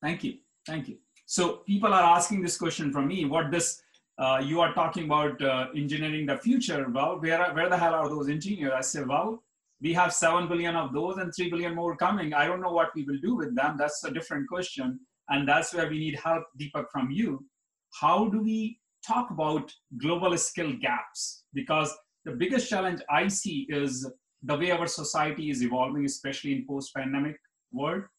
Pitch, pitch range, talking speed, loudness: 165 Hz, 145-180 Hz, 200 wpm, -28 LUFS